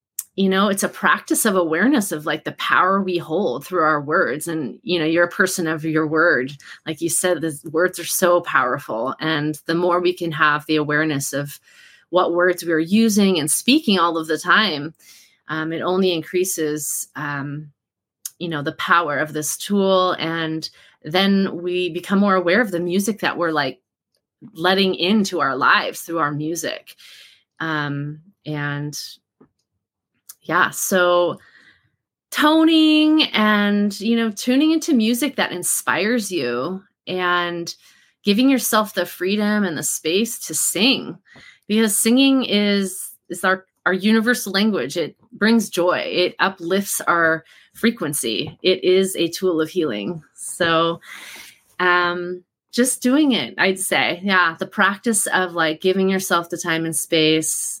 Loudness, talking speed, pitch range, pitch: -19 LUFS, 155 wpm, 160-200 Hz, 180 Hz